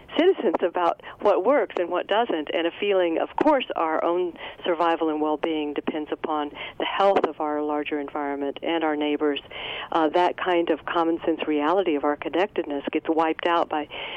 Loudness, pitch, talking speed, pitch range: -24 LUFS, 160 Hz, 180 wpm, 150-175 Hz